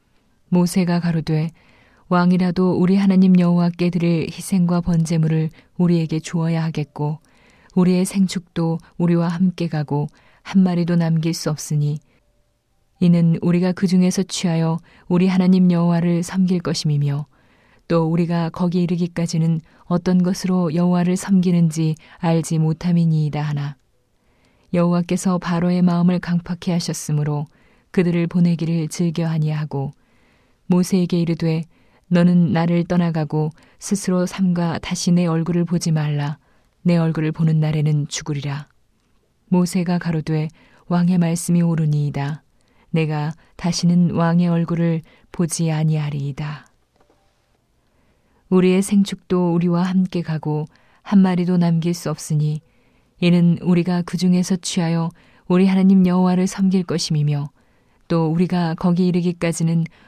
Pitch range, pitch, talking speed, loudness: 160-180 Hz, 170 Hz, 295 characters per minute, -19 LUFS